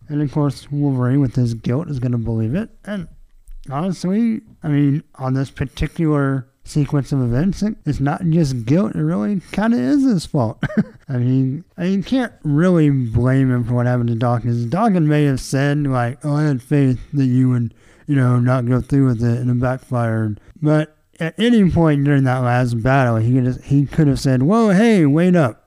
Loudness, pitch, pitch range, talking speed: -18 LUFS, 140 Hz, 125-160 Hz, 205 wpm